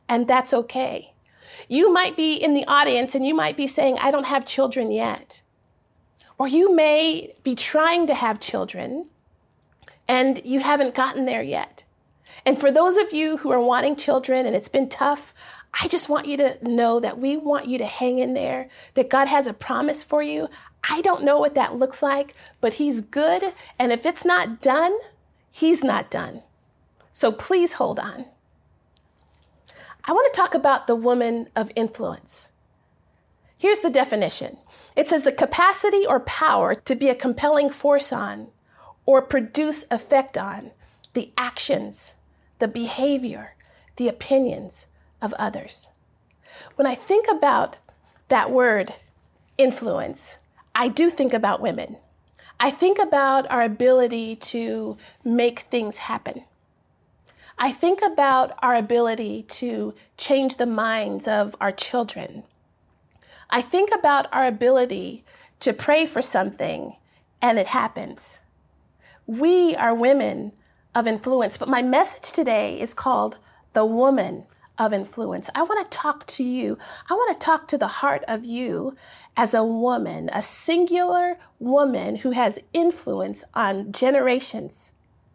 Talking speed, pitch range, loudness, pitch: 150 wpm, 235-295 Hz, -21 LUFS, 265 Hz